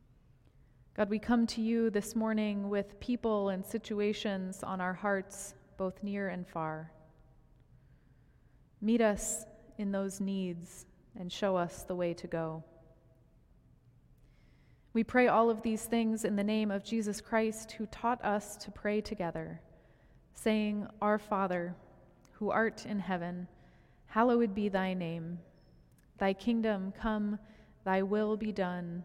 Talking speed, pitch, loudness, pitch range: 135 wpm, 205 Hz, -34 LUFS, 185-220 Hz